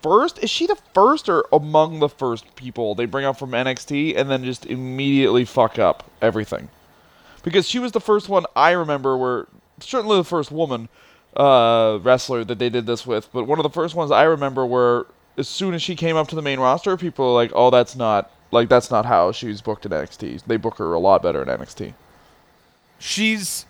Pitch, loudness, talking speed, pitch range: 135 Hz, -19 LUFS, 215 wpm, 120-165 Hz